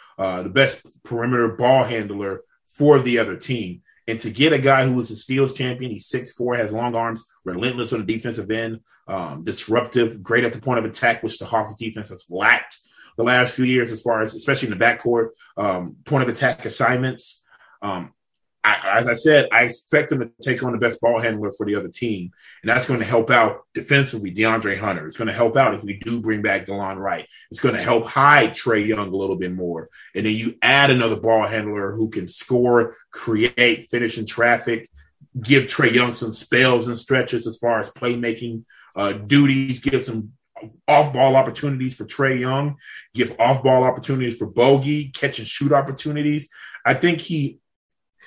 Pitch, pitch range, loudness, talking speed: 120 Hz, 110-130 Hz, -20 LUFS, 200 wpm